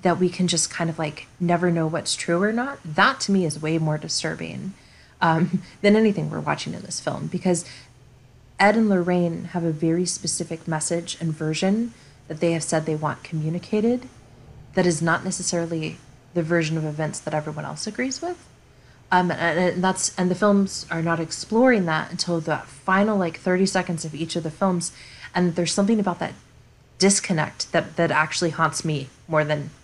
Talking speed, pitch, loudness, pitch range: 190 wpm, 170 Hz, -23 LUFS, 155-185 Hz